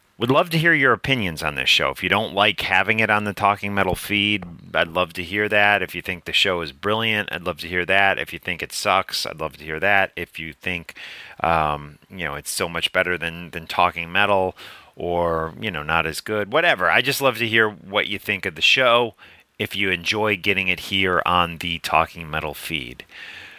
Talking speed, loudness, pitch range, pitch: 230 wpm, -20 LUFS, 85-105 Hz, 90 Hz